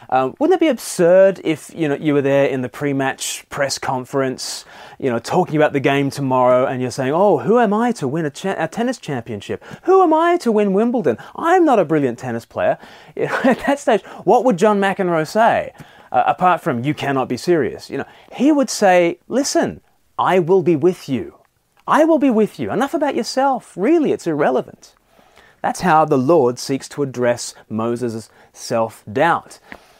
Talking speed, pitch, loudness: 190 wpm, 170 Hz, -17 LUFS